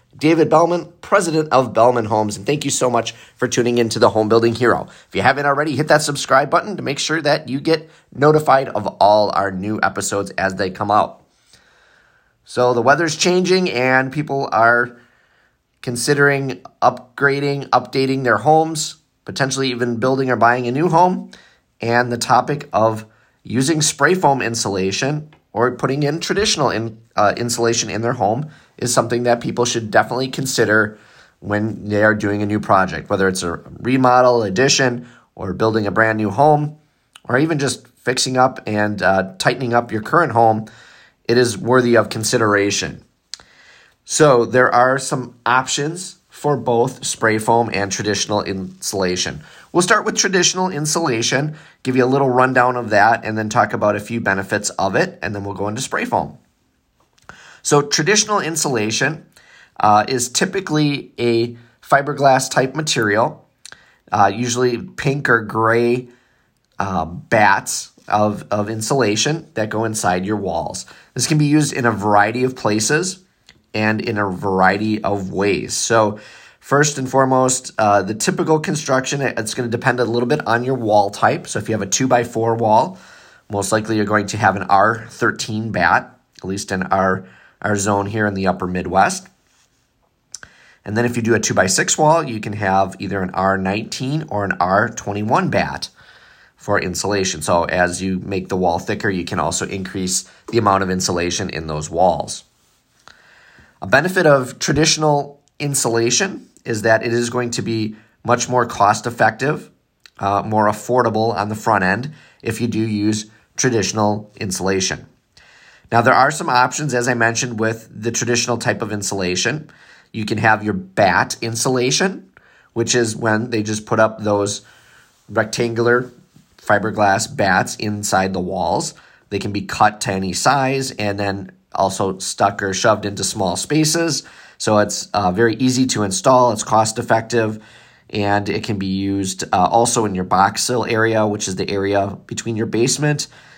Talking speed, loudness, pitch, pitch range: 165 wpm, -17 LUFS, 115 Hz, 105-135 Hz